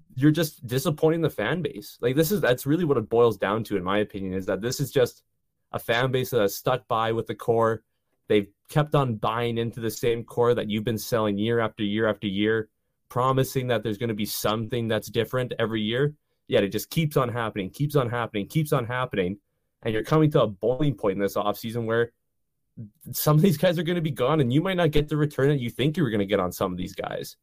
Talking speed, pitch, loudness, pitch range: 250 wpm, 120 Hz, -25 LUFS, 110-145 Hz